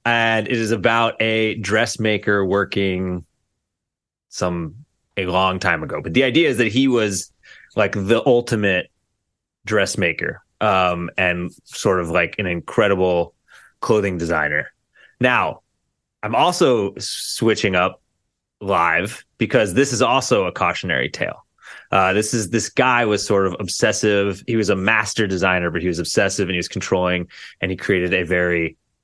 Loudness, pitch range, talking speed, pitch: -19 LUFS, 90-110 Hz, 150 wpm, 100 Hz